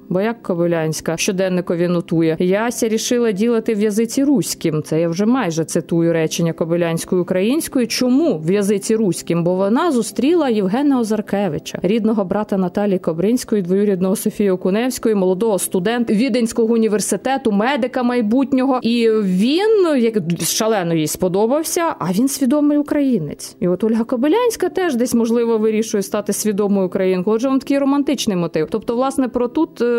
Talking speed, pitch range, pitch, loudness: 140 wpm, 185-250 Hz, 220 Hz, -17 LUFS